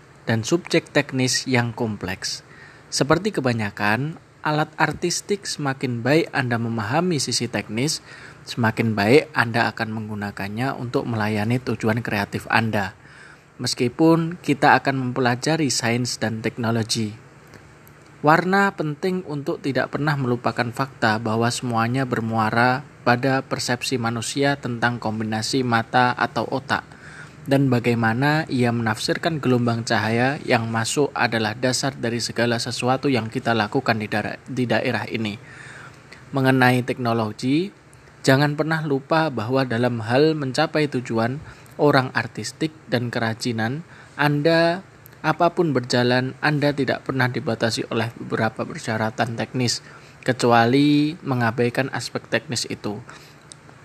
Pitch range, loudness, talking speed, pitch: 115-145 Hz, -22 LUFS, 115 wpm, 125 Hz